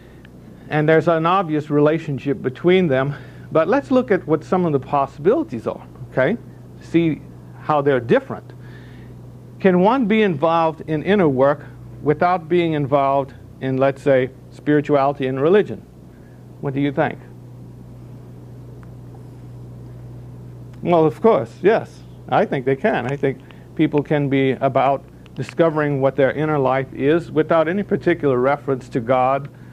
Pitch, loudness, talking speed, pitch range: 140 Hz, -19 LUFS, 135 wpm, 125-160 Hz